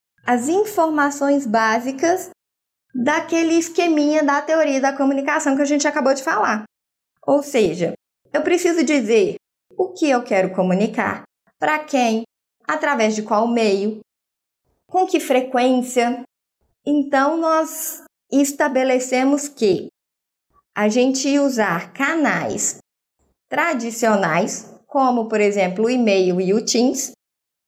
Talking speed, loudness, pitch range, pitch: 110 wpm, -19 LUFS, 230-305 Hz, 275 Hz